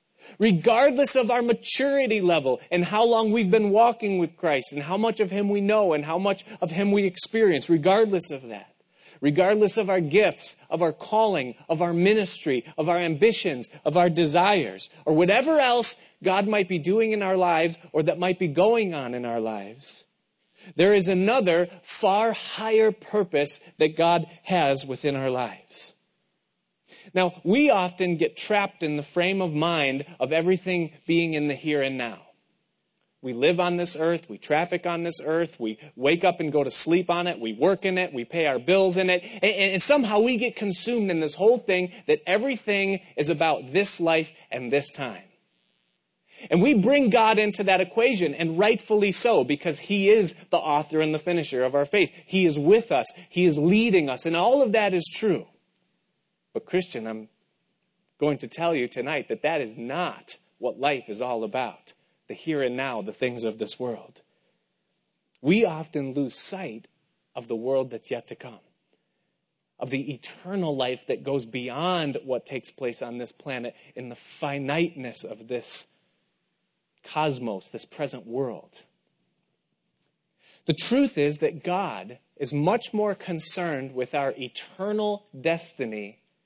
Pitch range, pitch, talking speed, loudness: 150-205 Hz, 175 Hz, 175 wpm, -24 LUFS